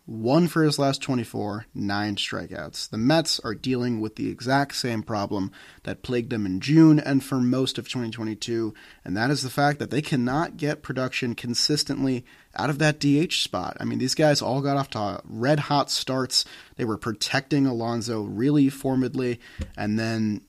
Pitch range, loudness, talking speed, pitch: 115-145 Hz, -24 LUFS, 180 wpm, 130 Hz